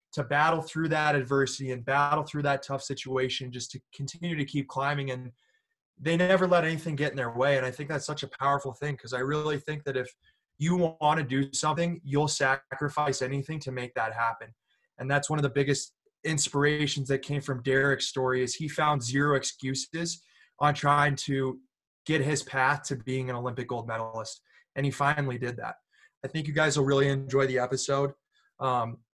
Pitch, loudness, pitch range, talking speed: 140 Hz, -28 LUFS, 130-150 Hz, 200 wpm